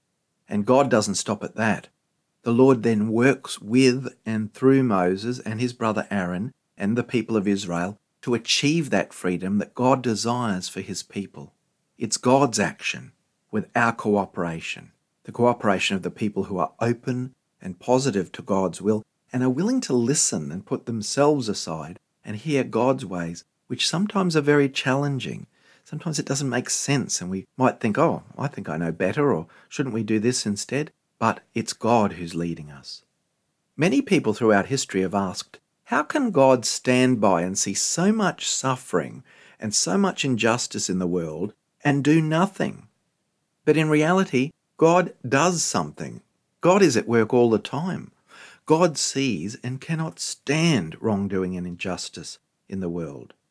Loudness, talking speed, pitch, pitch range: -23 LUFS, 165 wpm, 125 Hz, 100-145 Hz